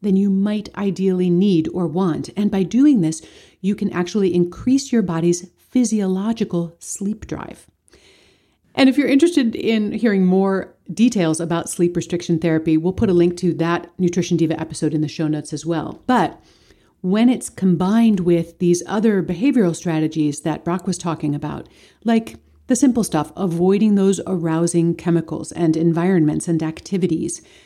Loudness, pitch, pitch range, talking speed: -19 LUFS, 180 Hz, 170-205 Hz, 160 wpm